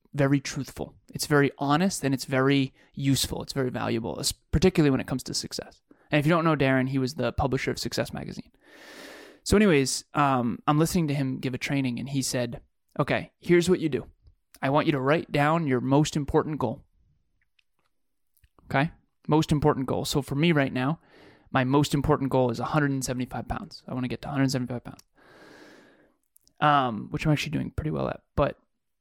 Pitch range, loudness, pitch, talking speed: 130-150 Hz, -26 LUFS, 140 Hz, 190 wpm